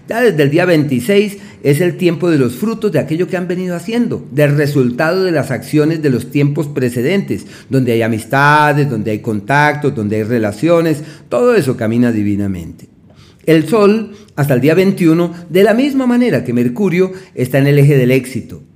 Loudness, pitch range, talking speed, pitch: -13 LUFS, 125-180 Hz, 180 wpm, 150 Hz